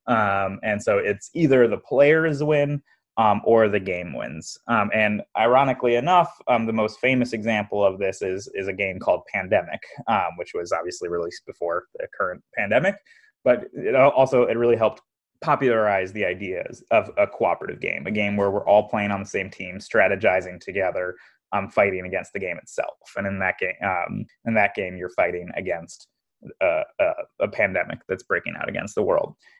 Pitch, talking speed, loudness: 115 Hz, 180 wpm, -23 LUFS